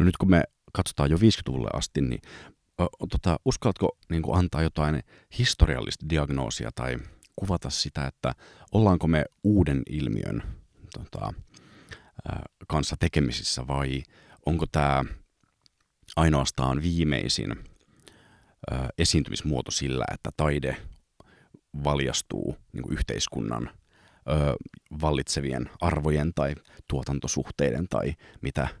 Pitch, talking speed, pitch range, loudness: 75 Hz, 100 wpm, 70-80 Hz, -27 LUFS